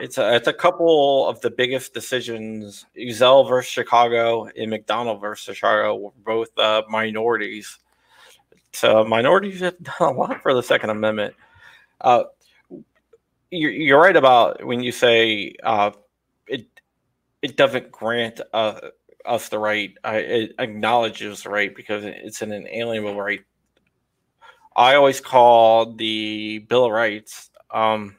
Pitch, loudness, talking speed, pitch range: 115 Hz, -19 LUFS, 140 wpm, 110-130 Hz